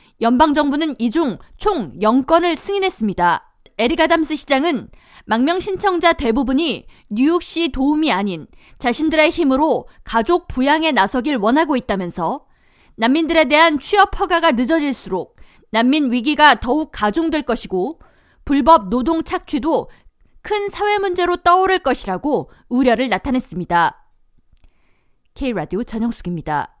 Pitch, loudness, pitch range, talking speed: 290 Hz, -17 LUFS, 230-330 Hz, 295 characters per minute